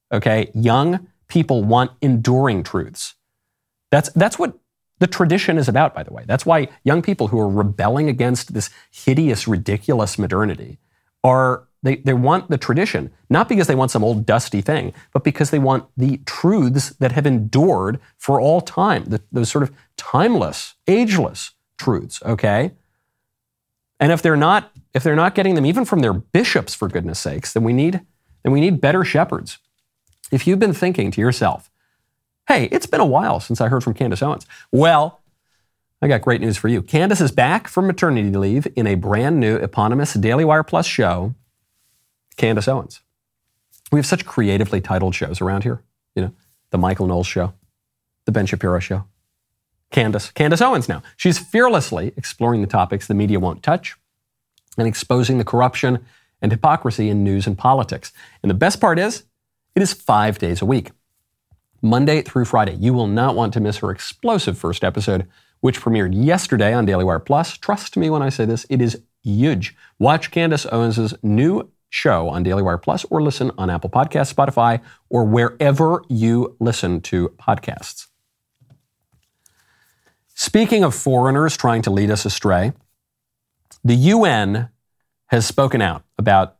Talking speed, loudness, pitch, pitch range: 165 wpm, -18 LUFS, 120 Hz, 105-145 Hz